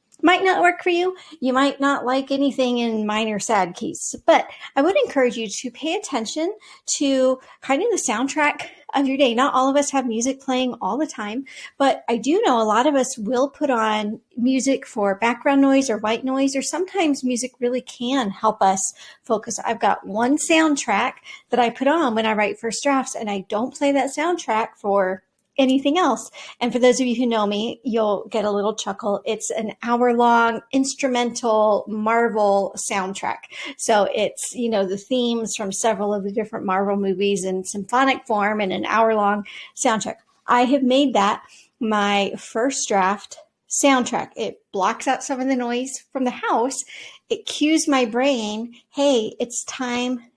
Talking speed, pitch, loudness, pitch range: 185 wpm, 245 Hz, -21 LUFS, 215-270 Hz